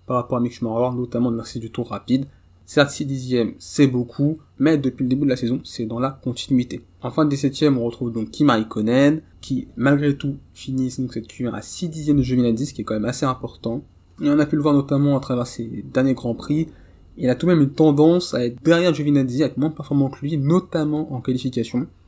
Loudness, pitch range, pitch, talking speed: -21 LUFS, 120-145 Hz, 130 Hz, 235 wpm